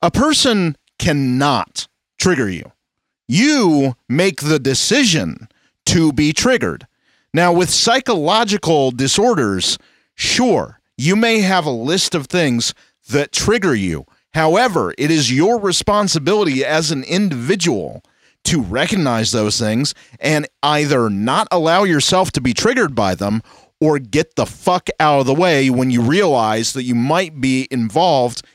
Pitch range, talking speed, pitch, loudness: 130-185 Hz, 135 wpm, 150 Hz, -16 LUFS